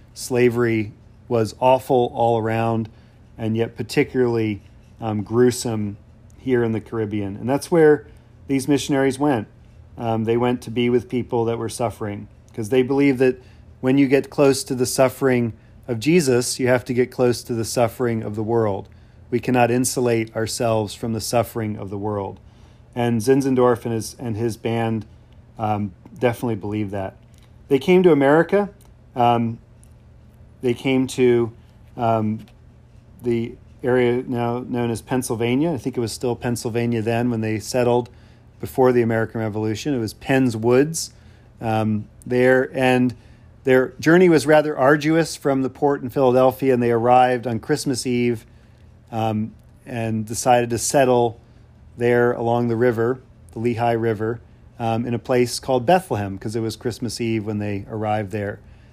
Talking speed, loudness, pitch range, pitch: 155 wpm, -20 LUFS, 110-125 Hz, 115 Hz